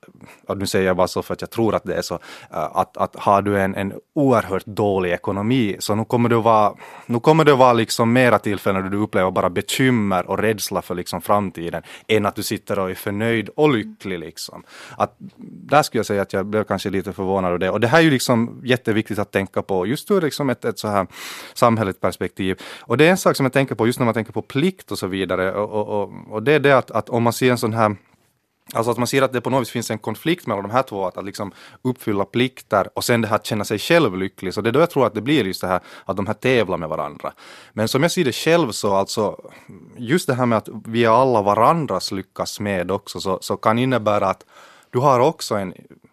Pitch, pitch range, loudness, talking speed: 110 Hz, 100-125 Hz, -20 LUFS, 250 wpm